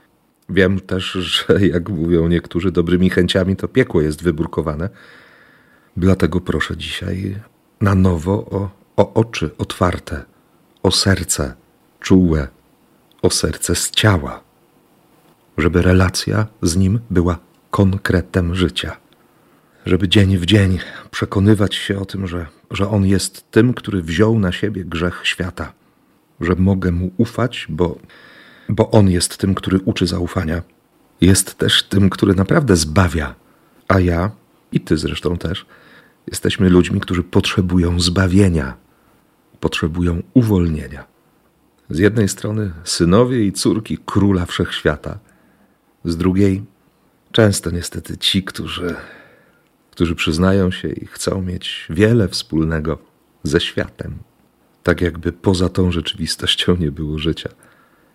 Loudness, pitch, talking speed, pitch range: -17 LUFS, 95 Hz, 120 wpm, 85-100 Hz